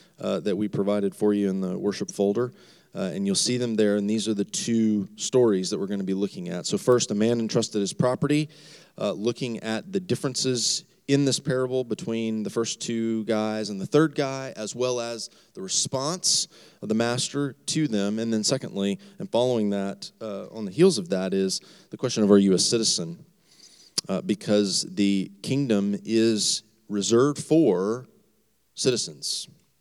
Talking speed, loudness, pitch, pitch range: 185 wpm, -25 LUFS, 115 Hz, 105-140 Hz